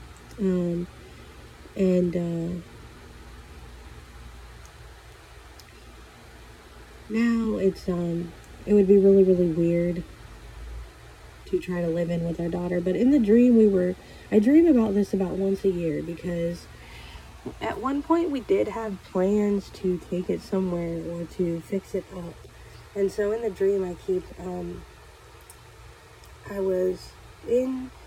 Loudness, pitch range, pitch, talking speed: -24 LUFS, 165-195 Hz, 180 Hz, 135 wpm